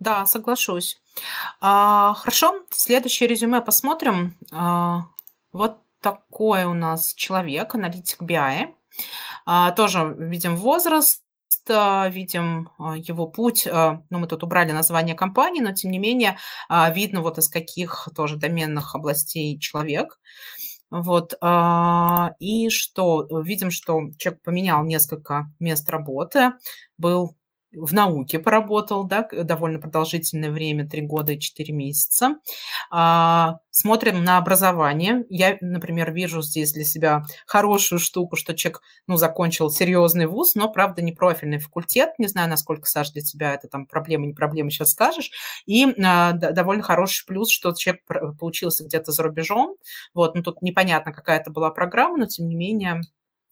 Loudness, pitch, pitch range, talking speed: -21 LUFS, 175 Hz, 160-200 Hz, 130 wpm